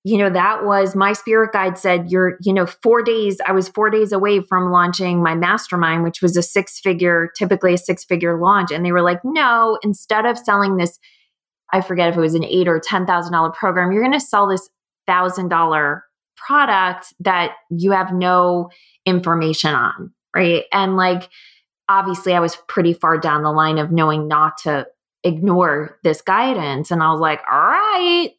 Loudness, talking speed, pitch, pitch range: -17 LUFS, 185 wpm, 185 Hz, 170-200 Hz